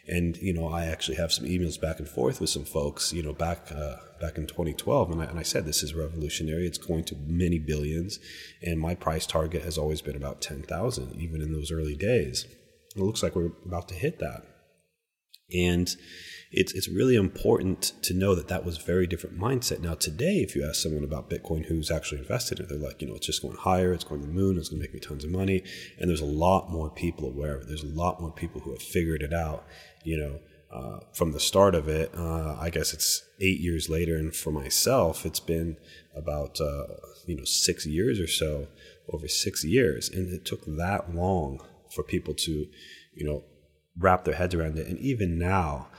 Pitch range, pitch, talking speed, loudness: 75-90 Hz, 80 Hz, 225 wpm, -29 LUFS